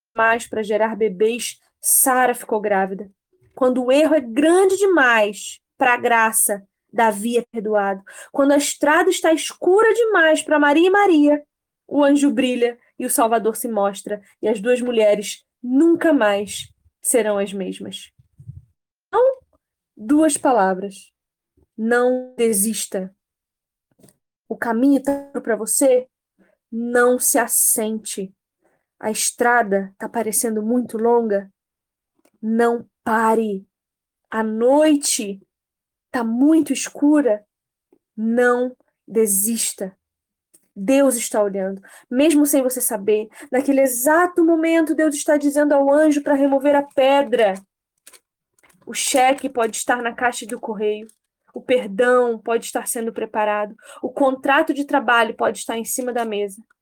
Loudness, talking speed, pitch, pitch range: -18 LUFS, 125 wpm, 240 Hz, 215-280 Hz